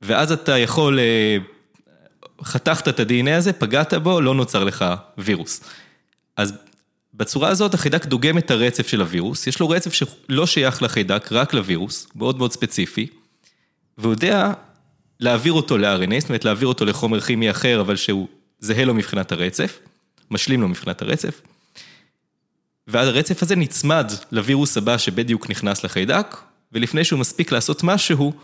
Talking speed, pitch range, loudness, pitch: 145 wpm, 110-155 Hz, -19 LUFS, 125 Hz